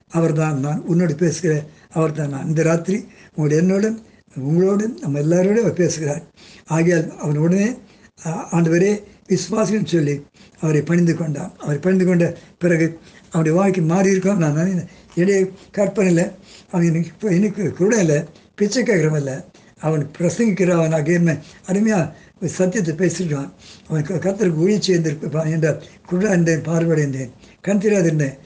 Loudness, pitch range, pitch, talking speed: -19 LUFS, 160-190 Hz, 170 Hz, 130 wpm